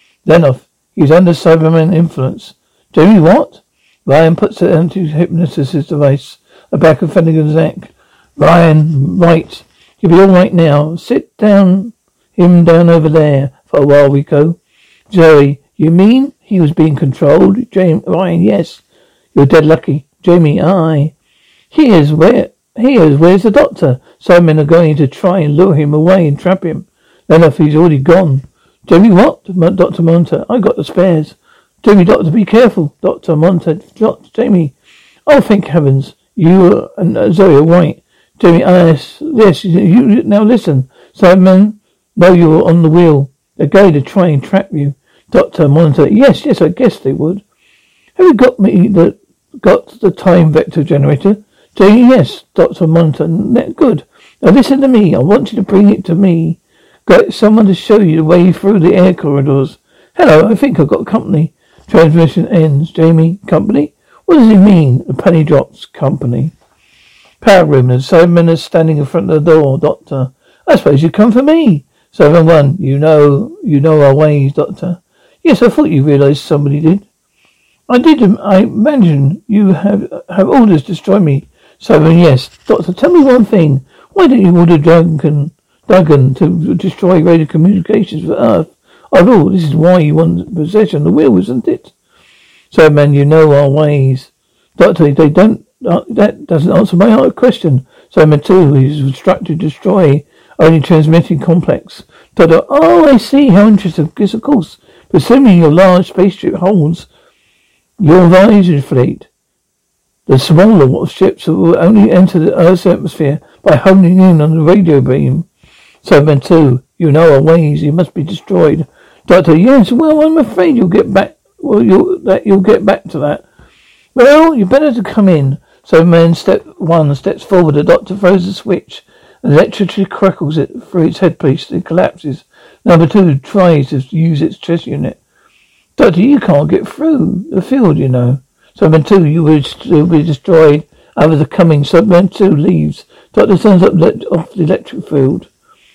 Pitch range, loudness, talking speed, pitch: 155-195 Hz, -8 LUFS, 170 wpm, 170 Hz